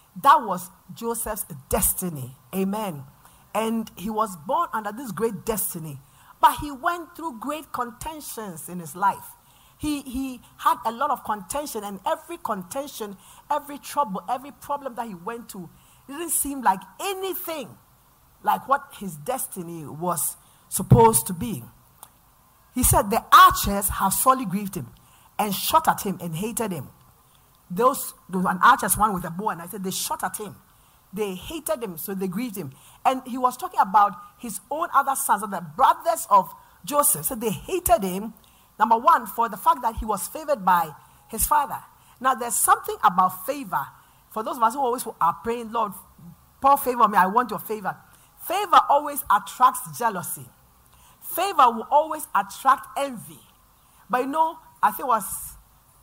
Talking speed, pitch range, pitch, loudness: 170 wpm, 195-285 Hz, 230 Hz, -23 LUFS